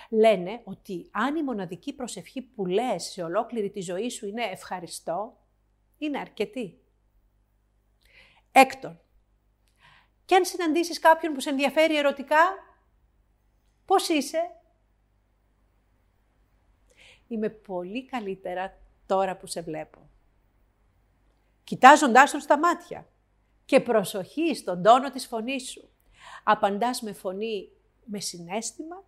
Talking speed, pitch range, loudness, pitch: 105 wpm, 170-285 Hz, -25 LUFS, 215 Hz